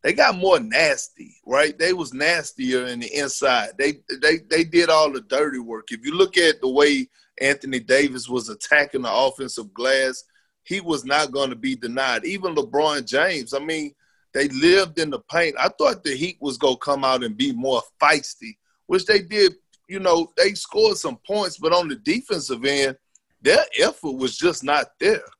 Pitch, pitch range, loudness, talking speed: 150 Hz, 135-195 Hz, -21 LUFS, 195 wpm